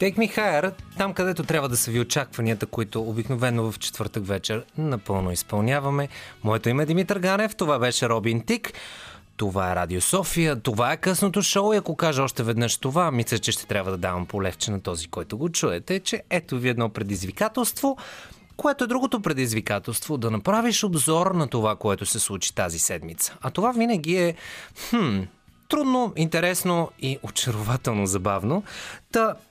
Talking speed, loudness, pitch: 165 wpm, -24 LUFS, 135 Hz